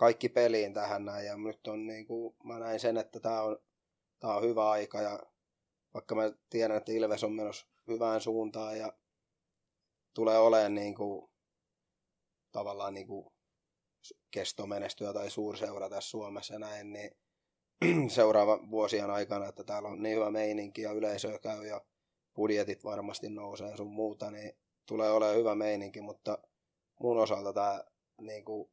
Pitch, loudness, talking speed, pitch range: 105 Hz, -34 LUFS, 145 wpm, 105-110 Hz